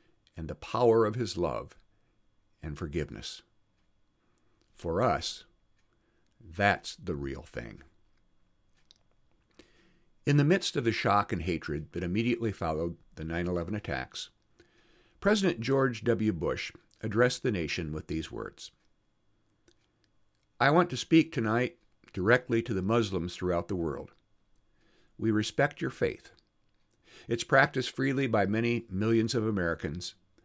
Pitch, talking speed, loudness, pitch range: 110 Hz, 125 wpm, -30 LUFS, 90-120 Hz